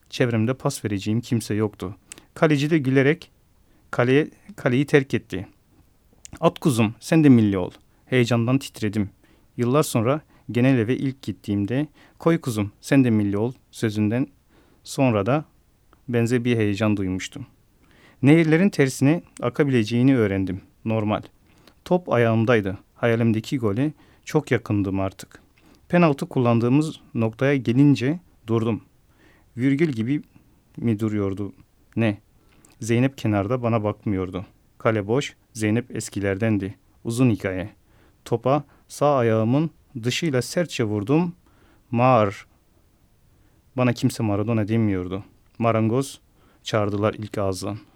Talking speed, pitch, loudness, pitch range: 110 wpm, 115 Hz, -22 LUFS, 105-135 Hz